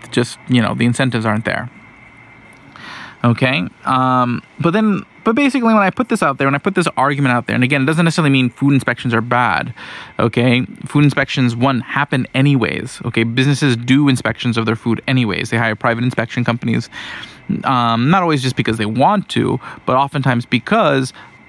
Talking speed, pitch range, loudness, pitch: 185 wpm, 120-140 Hz, -16 LUFS, 130 Hz